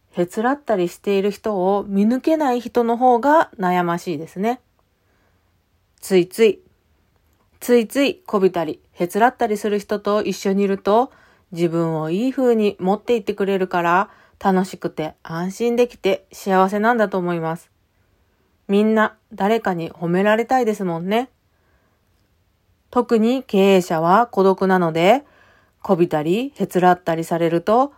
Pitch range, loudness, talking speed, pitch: 165-220 Hz, -19 LUFS, 290 characters per minute, 190 Hz